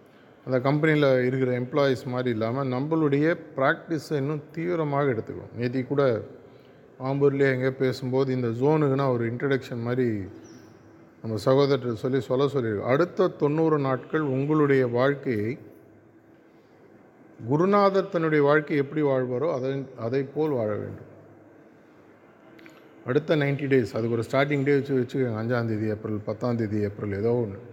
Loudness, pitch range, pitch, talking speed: -25 LUFS, 120-145 Hz, 135 Hz, 125 wpm